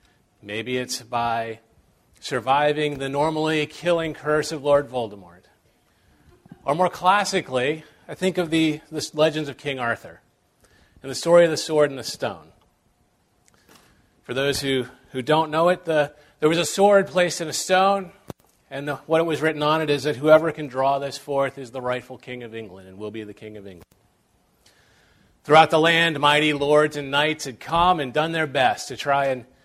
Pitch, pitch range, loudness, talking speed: 150 Hz, 130-160 Hz, -22 LUFS, 185 wpm